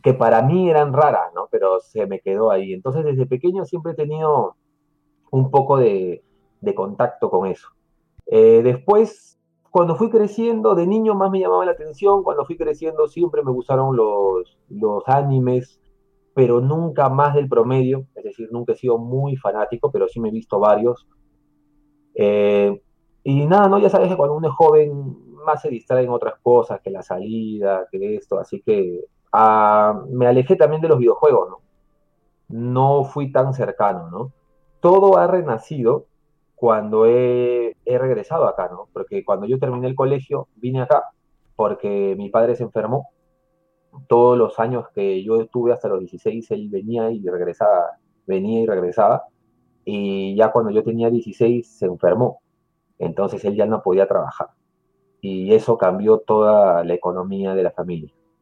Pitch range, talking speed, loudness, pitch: 115-175 Hz, 165 wpm, -18 LUFS, 135 Hz